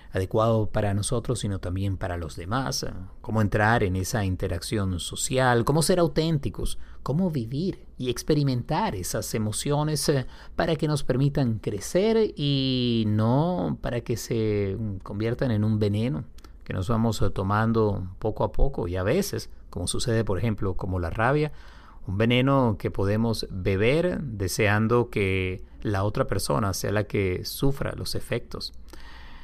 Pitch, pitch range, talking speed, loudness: 110 Hz, 100-130 Hz, 145 wpm, -26 LUFS